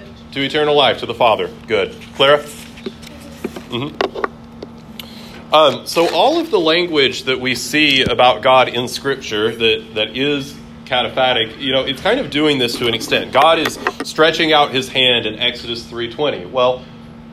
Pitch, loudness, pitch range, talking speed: 130 Hz, -15 LUFS, 115-145 Hz, 165 wpm